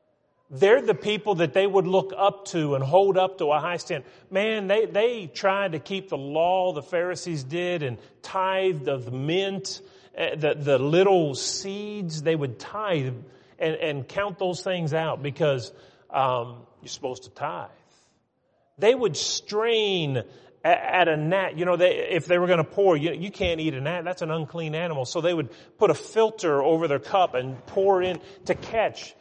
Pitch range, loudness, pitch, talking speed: 150-195 Hz, -25 LUFS, 175 Hz, 185 wpm